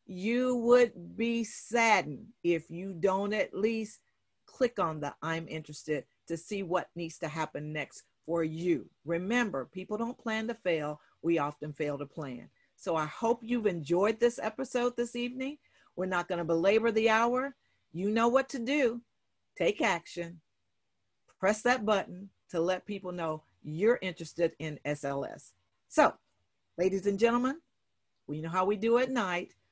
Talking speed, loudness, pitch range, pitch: 160 wpm, -31 LUFS, 160-230 Hz, 185 Hz